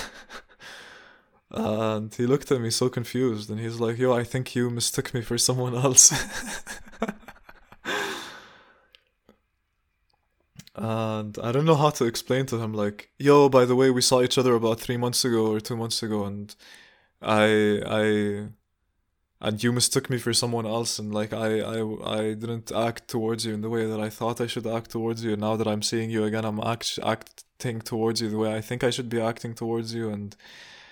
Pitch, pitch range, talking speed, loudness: 115 Hz, 110-125 Hz, 190 wpm, -25 LUFS